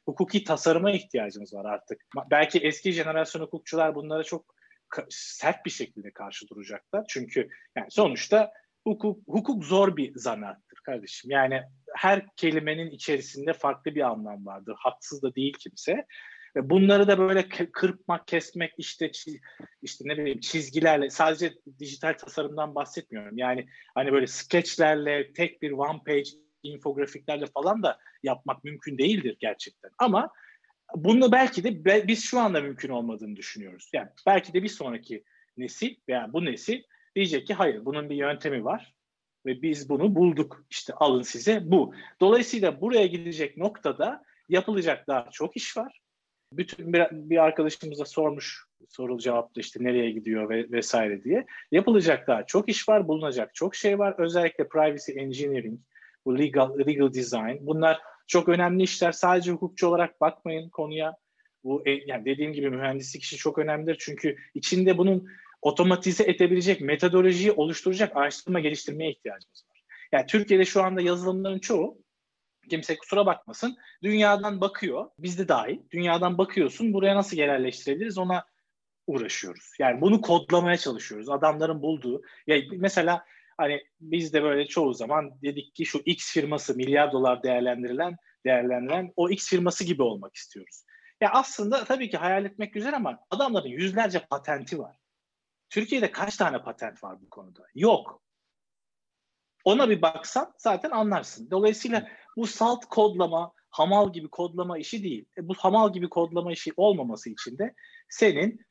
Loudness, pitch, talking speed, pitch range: -26 LUFS, 170 Hz, 145 wpm, 145-195 Hz